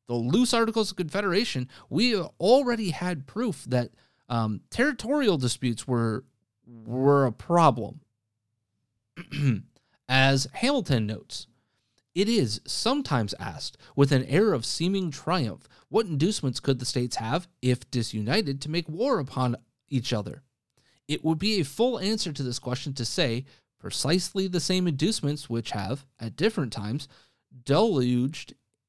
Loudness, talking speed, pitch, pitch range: -26 LUFS, 135 wpm, 135 Hz, 120-175 Hz